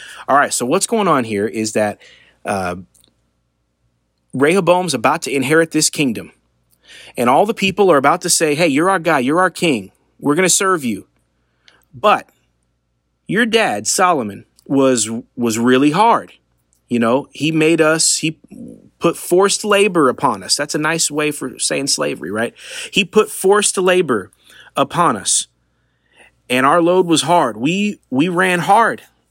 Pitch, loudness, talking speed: 150 Hz, -15 LUFS, 160 wpm